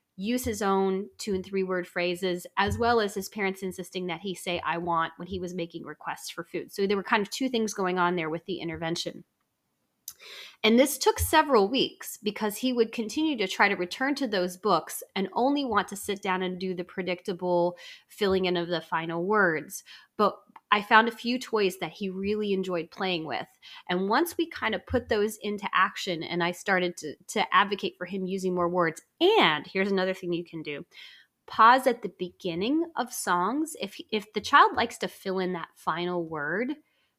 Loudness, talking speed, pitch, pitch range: -27 LUFS, 205 wpm, 190 Hz, 180-220 Hz